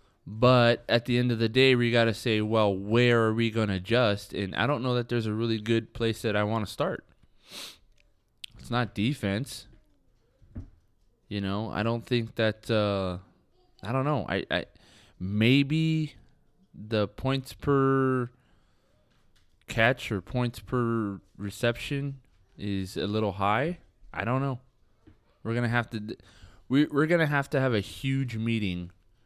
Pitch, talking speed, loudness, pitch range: 115 Hz, 165 wpm, -27 LUFS, 105-125 Hz